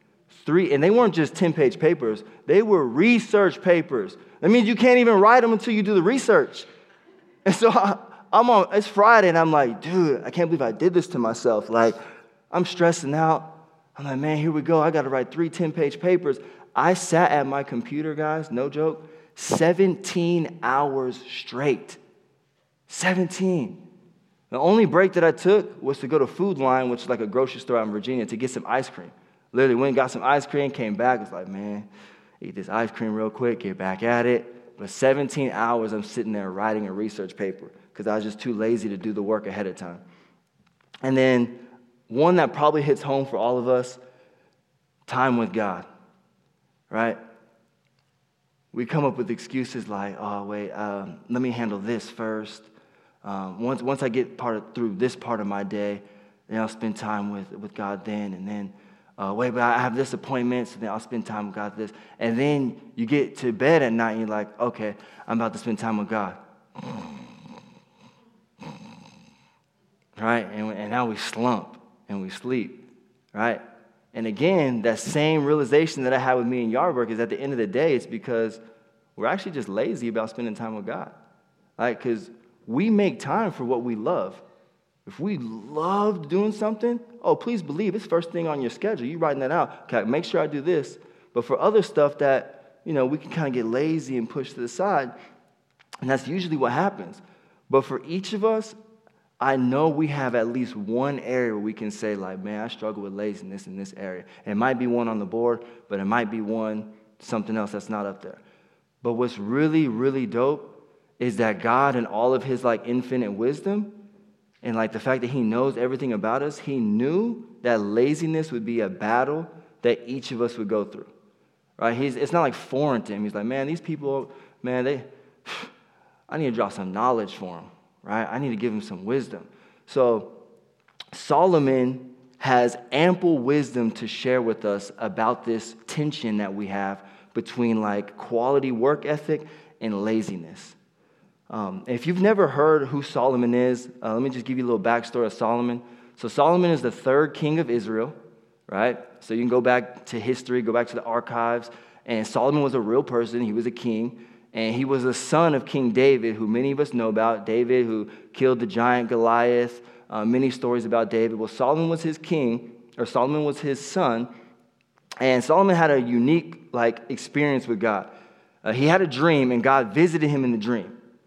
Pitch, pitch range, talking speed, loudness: 125 Hz, 115-155 Hz, 200 wpm, -24 LUFS